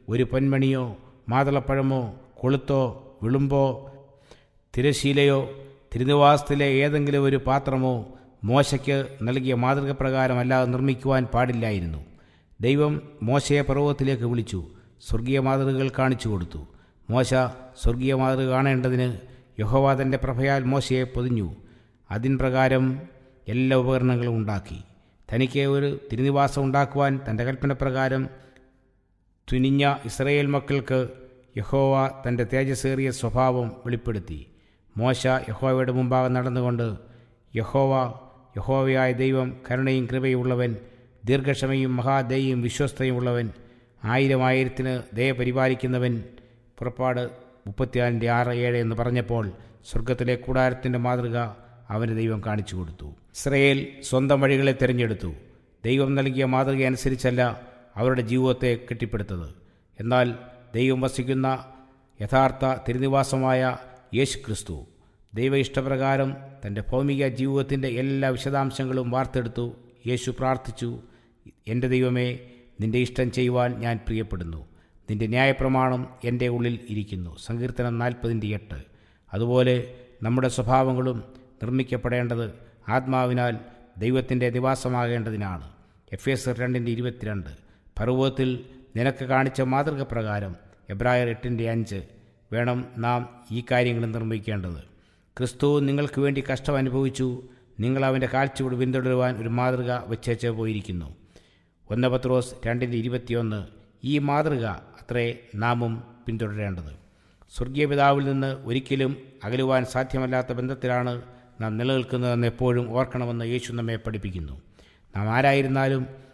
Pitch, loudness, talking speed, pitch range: 125 Hz, -25 LUFS, 95 wpm, 115-130 Hz